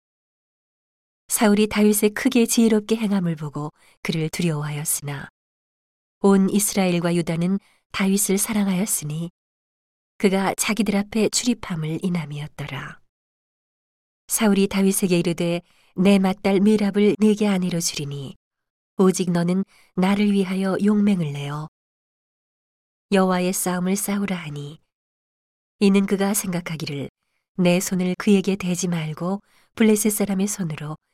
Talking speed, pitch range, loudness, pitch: 270 characters per minute, 170-205 Hz, -21 LUFS, 190 Hz